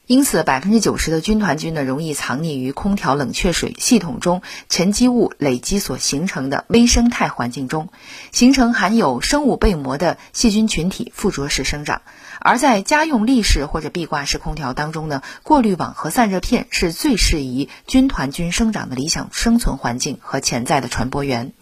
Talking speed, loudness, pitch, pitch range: 290 characters per minute, -18 LUFS, 175 Hz, 140-230 Hz